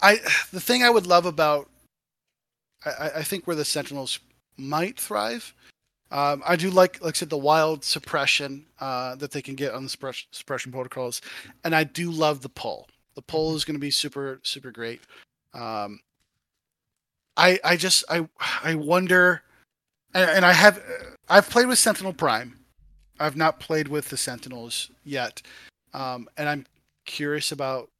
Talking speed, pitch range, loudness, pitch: 165 wpm, 135-175 Hz, -23 LUFS, 150 Hz